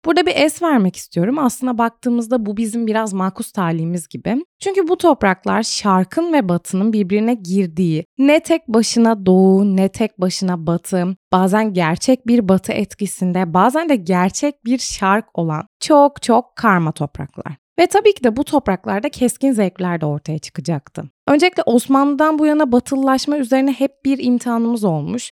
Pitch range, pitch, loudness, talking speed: 185-270 Hz, 225 Hz, -17 LUFS, 155 wpm